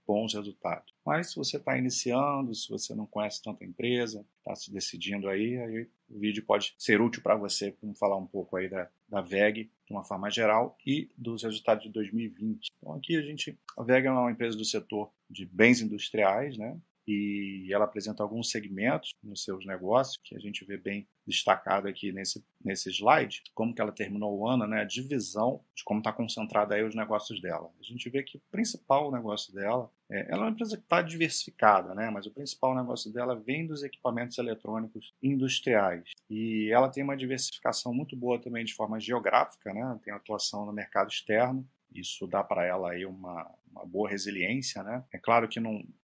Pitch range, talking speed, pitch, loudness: 105-125 Hz, 195 wpm, 110 Hz, -31 LUFS